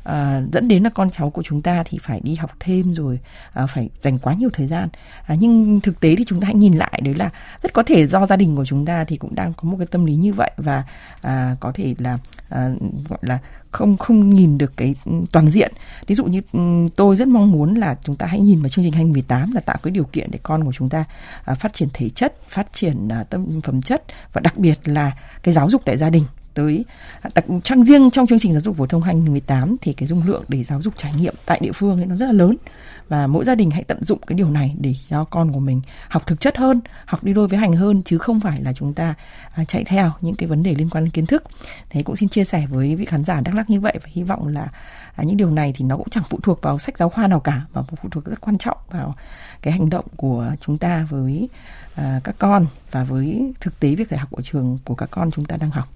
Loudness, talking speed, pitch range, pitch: -18 LUFS, 270 wpm, 145-190 Hz, 165 Hz